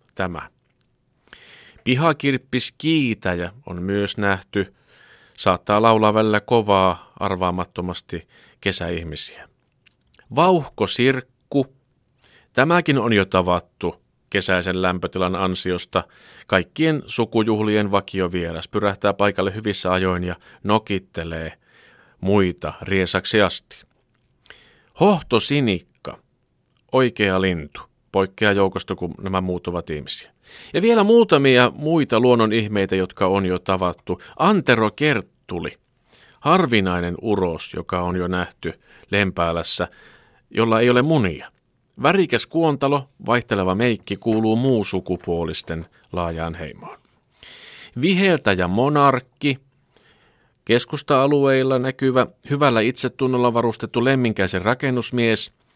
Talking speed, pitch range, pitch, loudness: 90 wpm, 95-130 Hz, 105 Hz, -20 LUFS